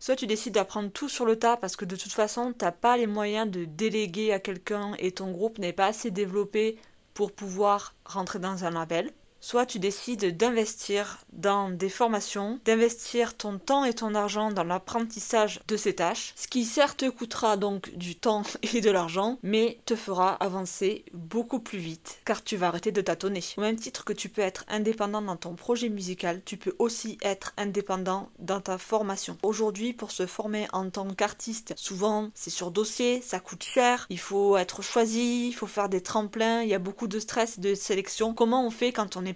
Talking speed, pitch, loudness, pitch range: 205 wpm, 210 Hz, -29 LUFS, 195-225 Hz